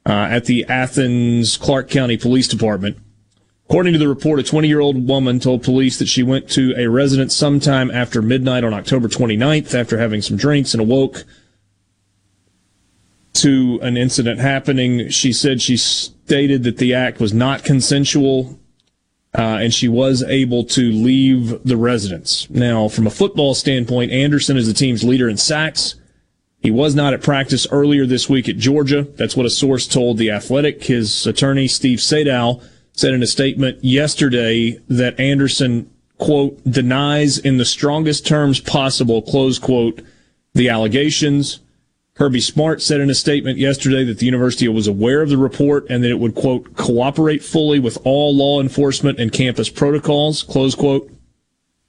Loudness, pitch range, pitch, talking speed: -15 LUFS, 120-140 Hz, 130 Hz, 165 wpm